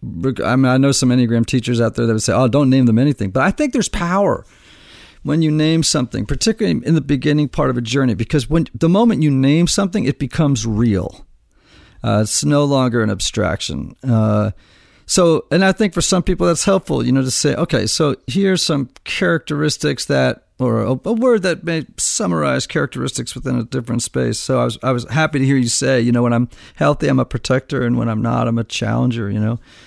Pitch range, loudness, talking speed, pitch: 120-160 Hz, -17 LUFS, 220 wpm, 135 Hz